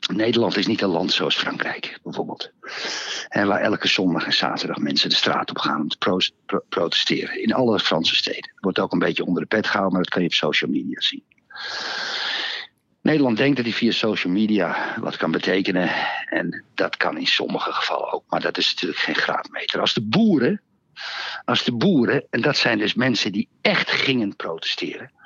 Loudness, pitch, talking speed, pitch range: -21 LUFS, 110 Hz, 195 wpm, 100-115 Hz